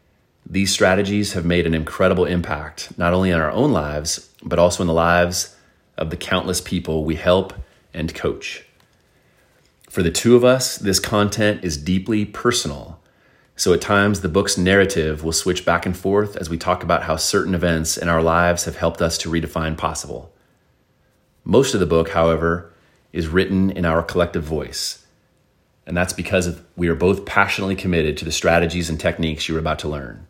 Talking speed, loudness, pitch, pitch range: 180 wpm, -19 LUFS, 85 Hz, 80-95 Hz